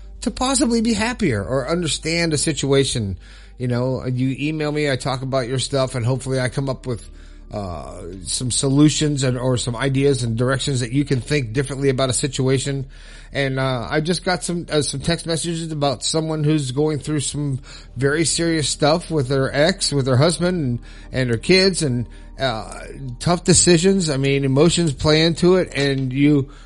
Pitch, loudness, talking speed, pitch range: 140 Hz, -19 LUFS, 185 wpm, 130-160 Hz